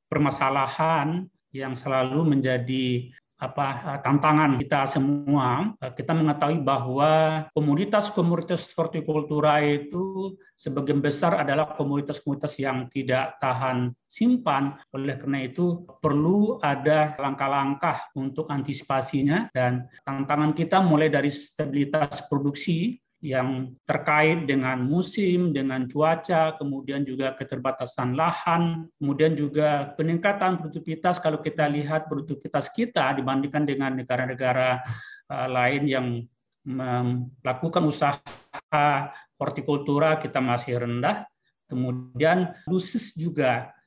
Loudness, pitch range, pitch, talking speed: -25 LUFS, 135-155 Hz, 145 Hz, 100 wpm